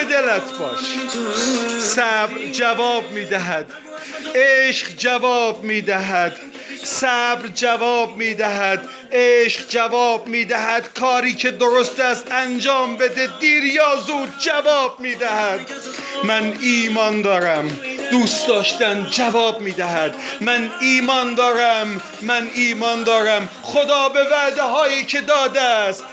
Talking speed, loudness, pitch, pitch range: 105 wpm, -18 LUFS, 245 Hz, 225-265 Hz